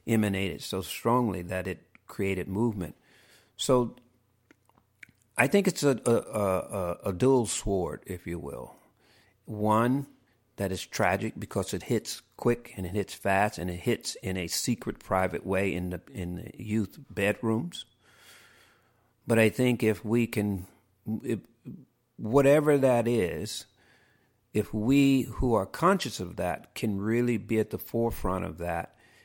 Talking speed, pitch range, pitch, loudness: 145 wpm, 95-120 Hz, 110 Hz, -29 LUFS